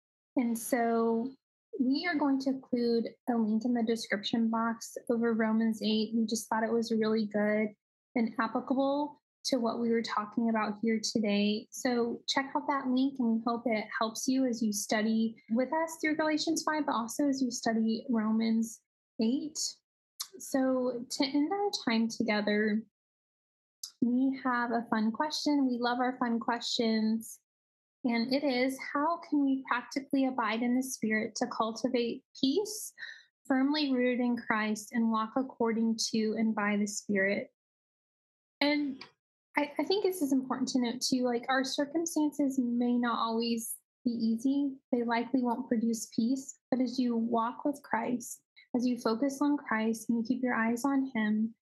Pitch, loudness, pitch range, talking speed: 240 Hz, -31 LUFS, 225-270 Hz, 165 wpm